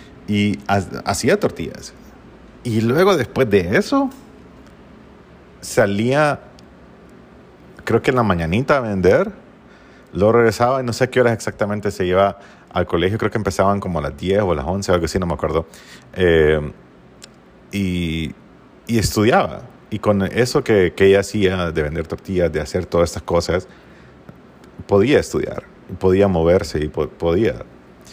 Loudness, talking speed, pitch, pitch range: -18 LUFS, 150 wpm, 100 Hz, 85-110 Hz